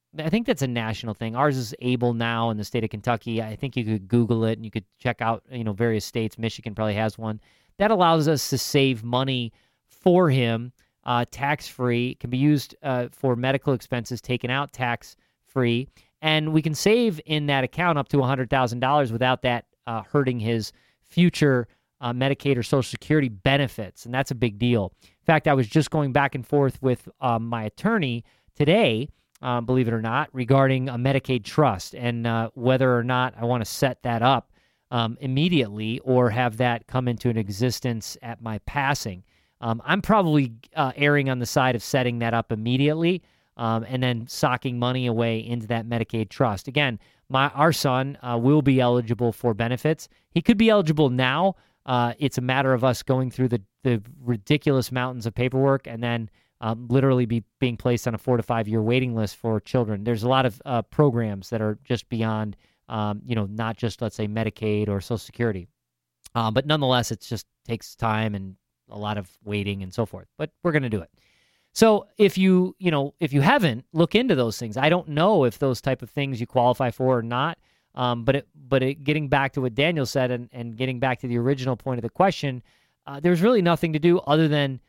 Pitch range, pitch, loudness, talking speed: 115-140 Hz, 125 Hz, -24 LUFS, 210 wpm